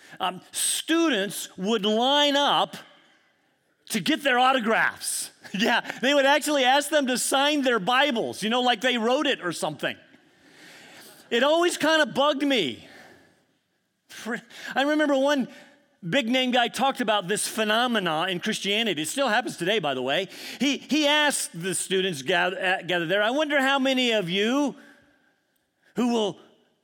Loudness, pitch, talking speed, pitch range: -24 LUFS, 250 Hz, 155 wpm, 205-280 Hz